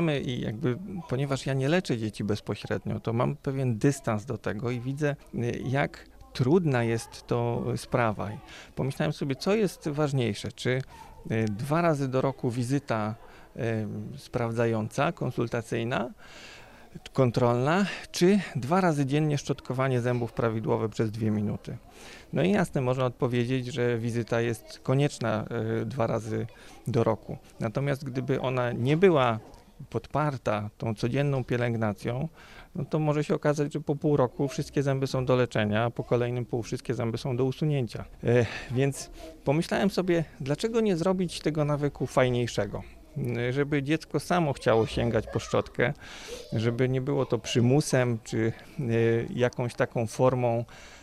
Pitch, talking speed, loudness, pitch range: 130 Hz, 135 wpm, -28 LUFS, 115-145 Hz